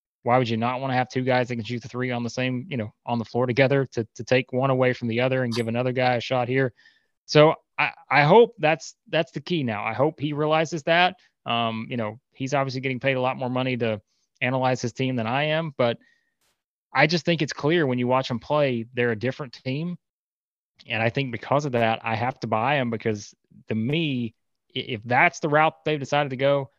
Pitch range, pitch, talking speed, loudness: 120-145 Hz, 130 Hz, 240 wpm, -24 LUFS